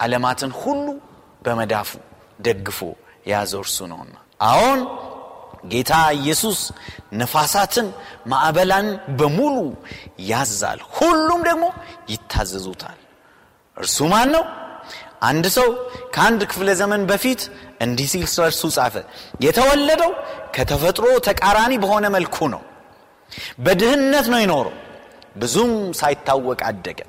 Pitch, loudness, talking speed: 185 Hz, -19 LUFS, 90 wpm